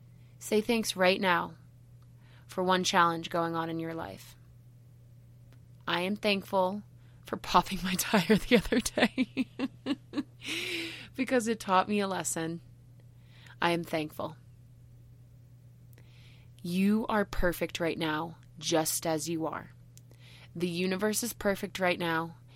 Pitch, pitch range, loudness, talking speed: 165 Hz, 125-190 Hz, -30 LUFS, 120 wpm